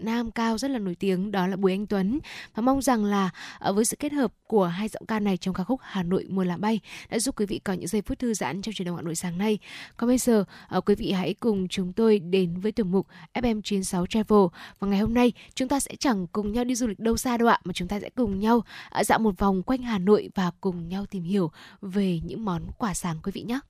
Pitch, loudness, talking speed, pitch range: 205 Hz, -26 LUFS, 270 wpm, 185-230 Hz